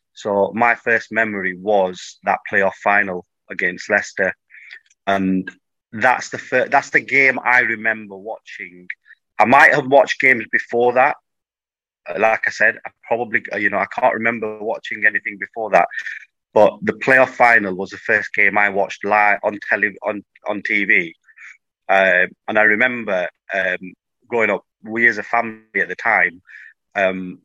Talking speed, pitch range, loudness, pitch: 155 wpm, 95-115 Hz, -17 LUFS, 105 Hz